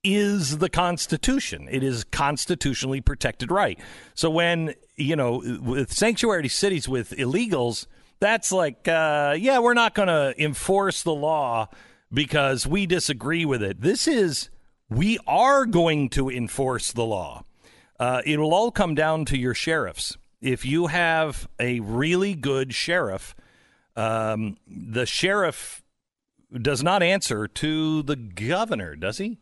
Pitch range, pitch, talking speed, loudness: 125-180 Hz, 150 Hz, 140 wpm, -23 LUFS